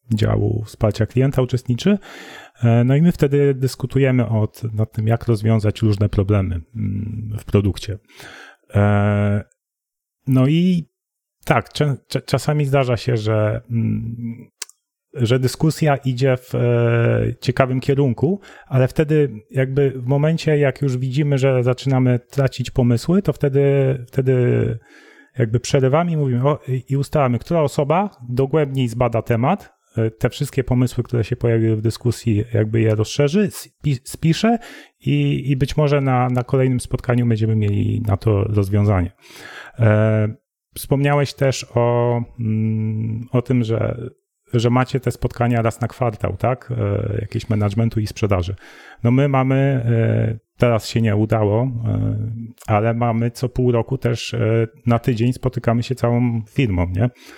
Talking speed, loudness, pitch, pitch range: 120 wpm, -19 LUFS, 120 Hz, 110-135 Hz